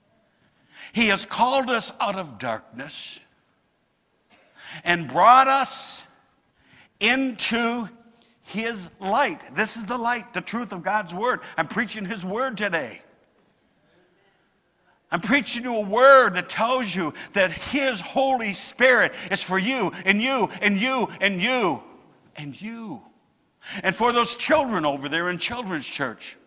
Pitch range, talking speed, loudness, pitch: 190-250 Hz, 140 wpm, -22 LUFS, 225 Hz